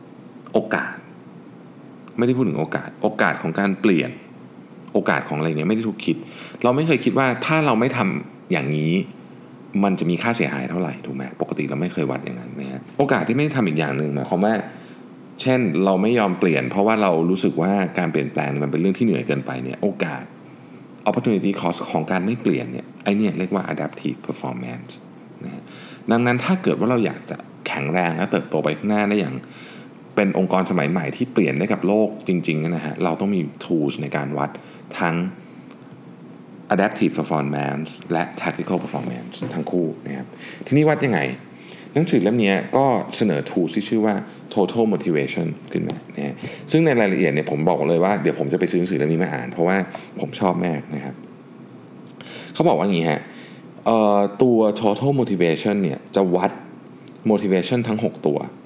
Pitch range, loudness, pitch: 75-110 Hz, -21 LUFS, 95 Hz